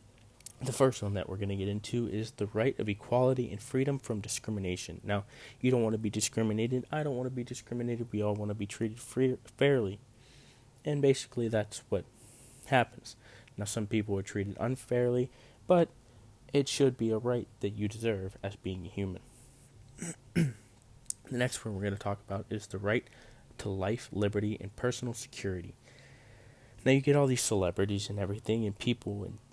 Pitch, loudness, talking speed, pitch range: 115 Hz, -33 LUFS, 185 wpm, 105-125 Hz